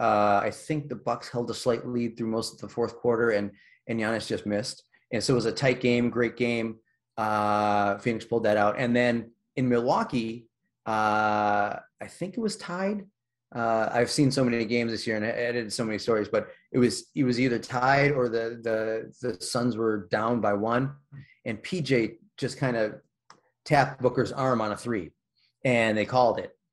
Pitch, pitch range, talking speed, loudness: 120 Hz, 110-125 Hz, 200 wpm, -27 LUFS